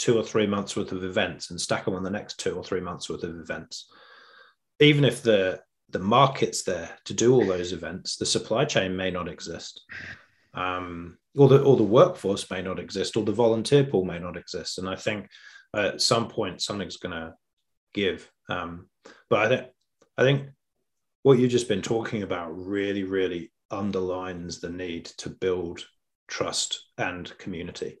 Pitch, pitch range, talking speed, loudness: 95 Hz, 90-115 Hz, 180 wpm, -26 LUFS